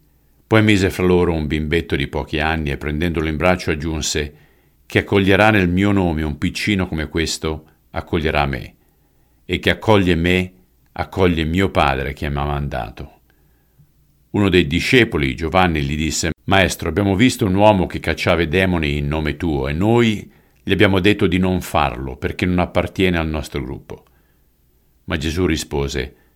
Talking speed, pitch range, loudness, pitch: 160 wpm, 75-95 Hz, -18 LUFS, 85 Hz